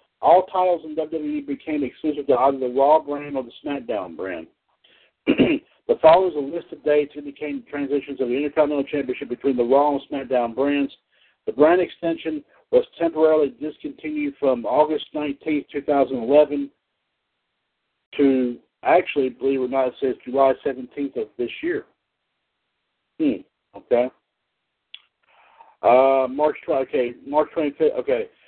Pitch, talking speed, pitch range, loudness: 145 Hz, 140 wpm, 135-170 Hz, -22 LUFS